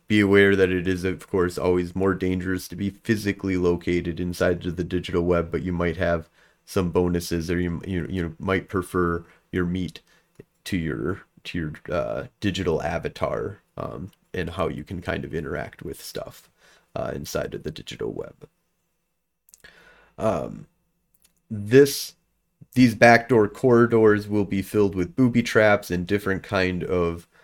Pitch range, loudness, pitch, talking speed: 90-105 Hz, -23 LUFS, 95 Hz, 155 wpm